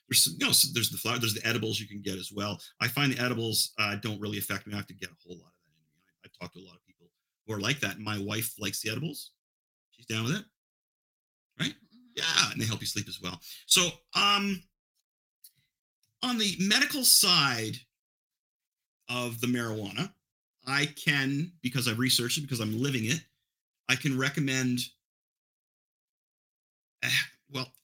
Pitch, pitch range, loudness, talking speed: 120 Hz, 105-145 Hz, -28 LUFS, 190 wpm